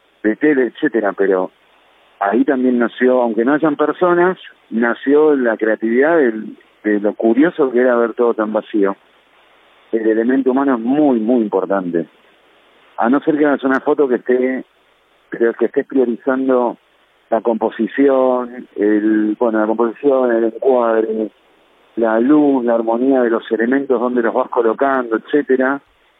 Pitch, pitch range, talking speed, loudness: 120 Hz, 110-135 Hz, 145 wpm, -16 LUFS